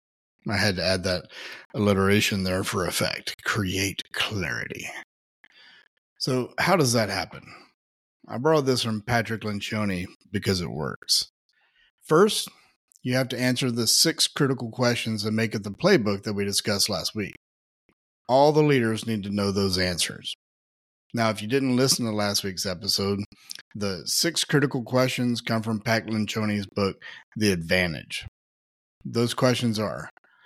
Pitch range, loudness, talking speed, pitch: 100-125 Hz, -24 LUFS, 150 wpm, 110 Hz